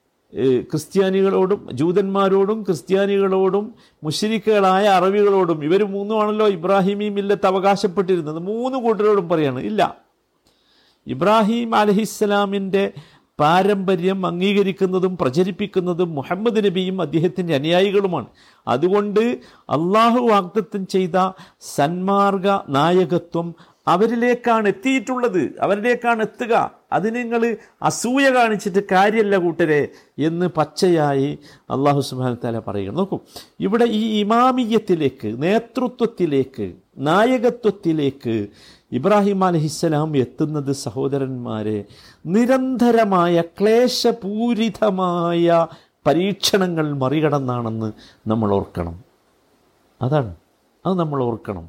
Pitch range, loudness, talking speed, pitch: 150-210 Hz, -19 LUFS, 75 wpm, 190 Hz